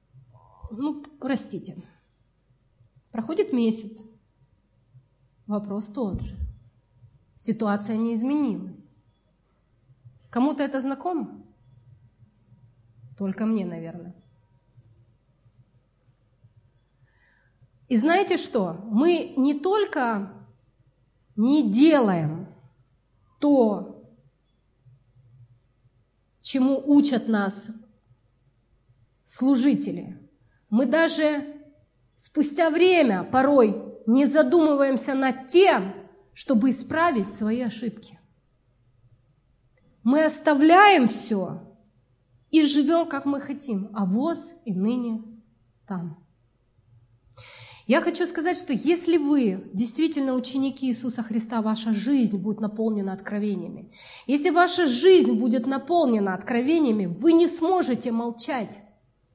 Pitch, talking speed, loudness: 215 Hz, 80 wpm, -23 LUFS